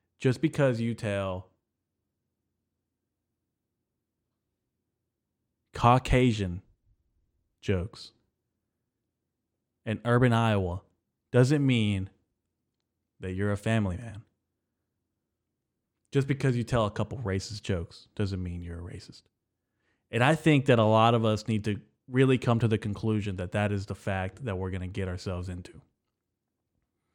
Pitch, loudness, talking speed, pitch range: 105 Hz, -28 LUFS, 125 wpm, 95-115 Hz